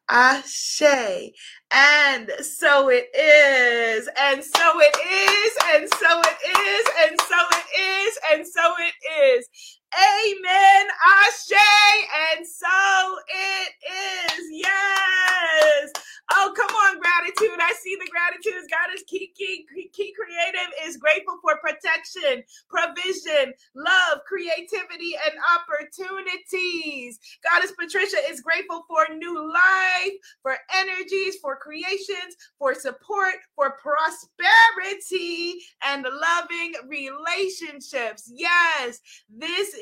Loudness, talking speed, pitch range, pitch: -19 LUFS, 105 wpm, 300-385 Hz, 345 Hz